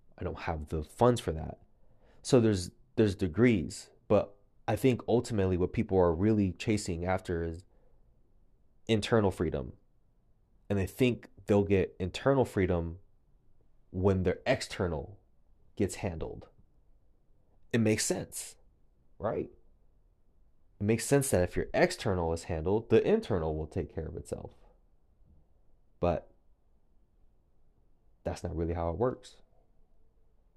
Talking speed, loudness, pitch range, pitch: 125 wpm, -31 LUFS, 85-110 Hz, 95 Hz